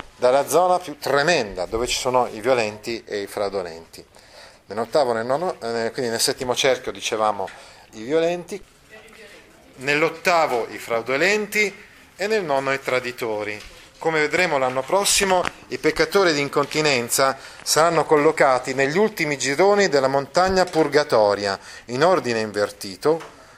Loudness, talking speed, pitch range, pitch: -21 LUFS, 120 wpm, 120-175 Hz, 140 Hz